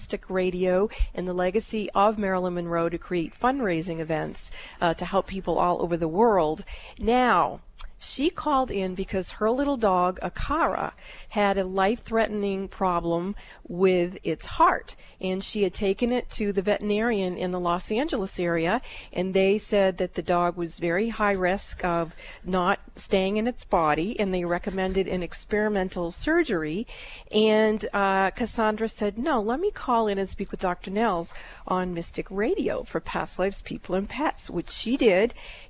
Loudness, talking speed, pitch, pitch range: -26 LUFS, 165 wpm, 195 Hz, 180-215 Hz